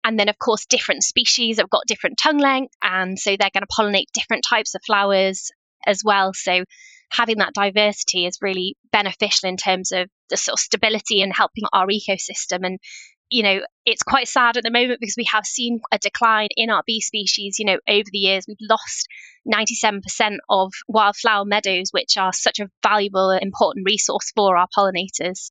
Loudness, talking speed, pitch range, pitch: -19 LUFS, 200 wpm, 195-230 Hz, 210 Hz